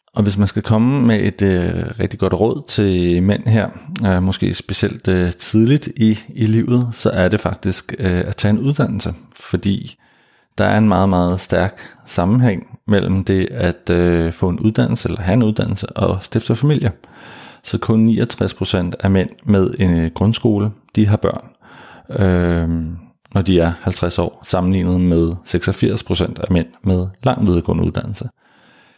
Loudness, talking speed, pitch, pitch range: -17 LUFS, 165 wpm, 100 Hz, 90-110 Hz